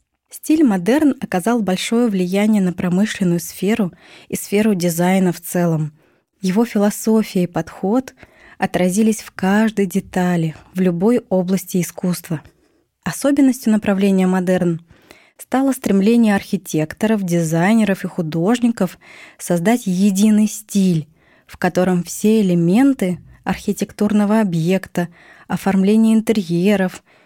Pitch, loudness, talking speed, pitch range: 195 Hz, -17 LUFS, 100 wpm, 180-215 Hz